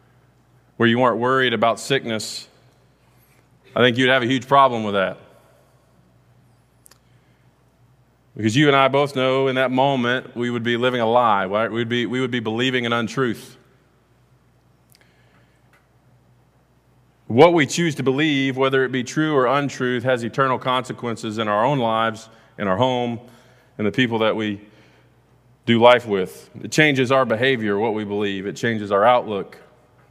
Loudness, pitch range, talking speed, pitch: -19 LUFS, 115-130 Hz, 155 wpm, 125 Hz